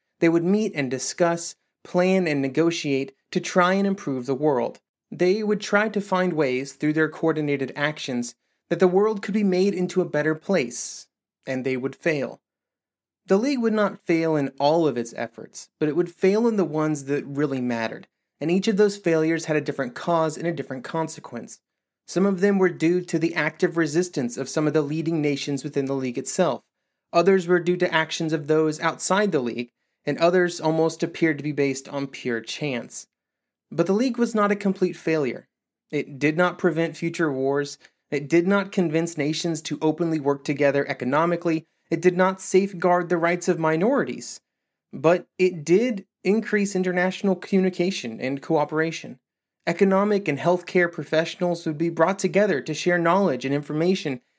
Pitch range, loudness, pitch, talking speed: 150-185 Hz, -23 LUFS, 165 Hz, 180 wpm